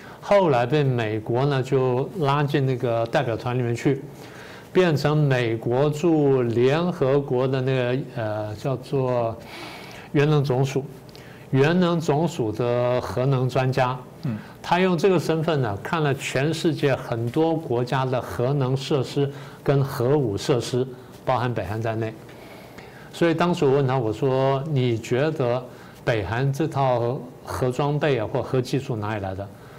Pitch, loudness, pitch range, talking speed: 135 Hz, -23 LUFS, 125-145 Hz, 210 characters per minute